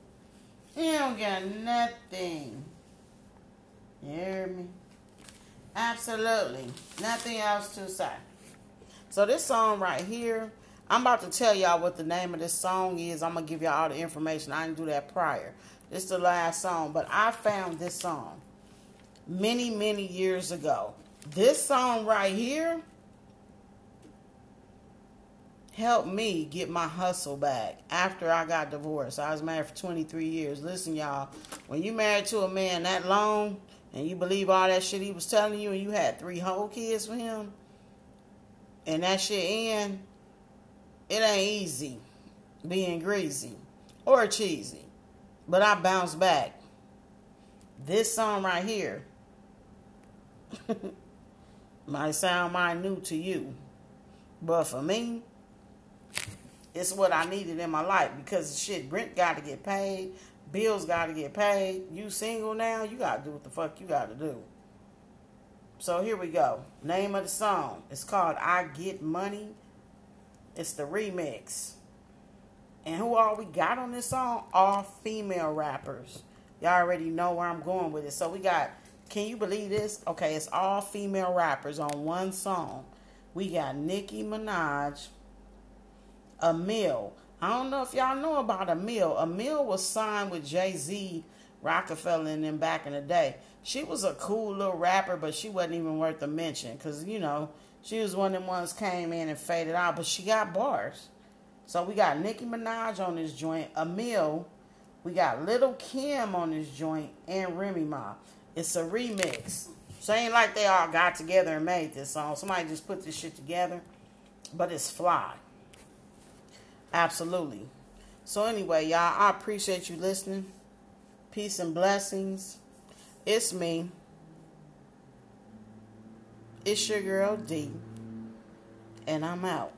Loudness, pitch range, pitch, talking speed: -30 LUFS, 165-210 Hz, 185 Hz, 155 wpm